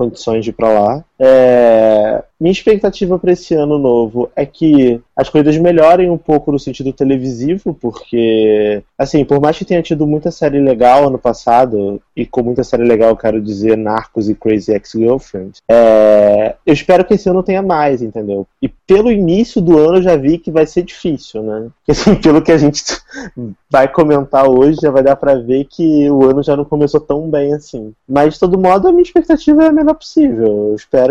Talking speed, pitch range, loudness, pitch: 200 wpm, 115-170 Hz, -11 LUFS, 140 Hz